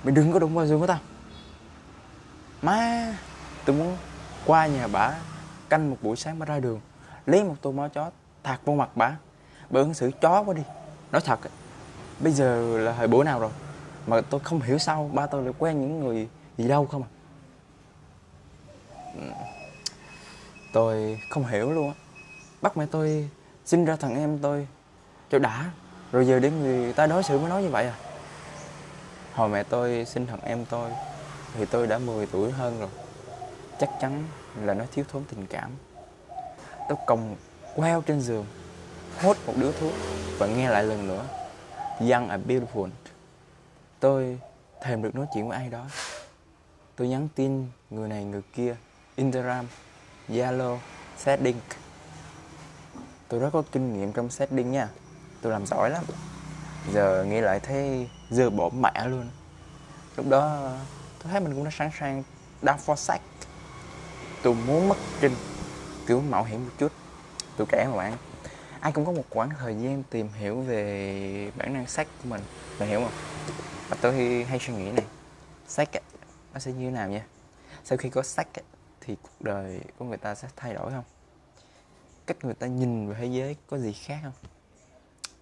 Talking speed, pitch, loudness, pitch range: 170 wpm, 130 Hz, -27 LUFS, 115-150 Hz